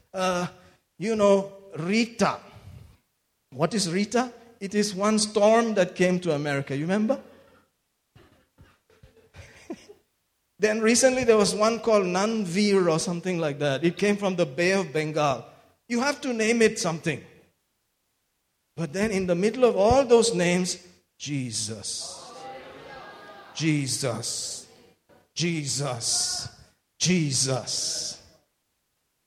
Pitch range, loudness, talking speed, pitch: 155-215 Hz, -24 LUFS, 115 wpm, 185 Hz